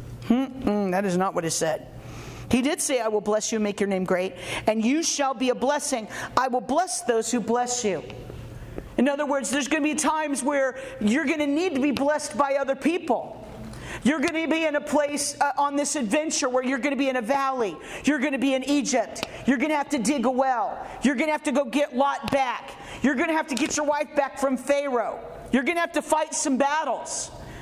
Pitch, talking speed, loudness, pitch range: 275 Hz, 245 wpm, -25 LUFS, 245-295 Hz